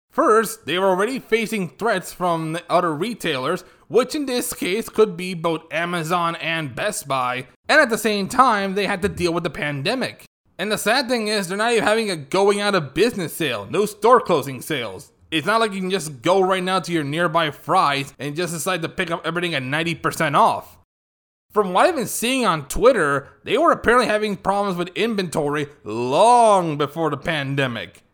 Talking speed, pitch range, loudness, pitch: 200 wpm, 160-215 Hz, -20 LUFS, 180 Hz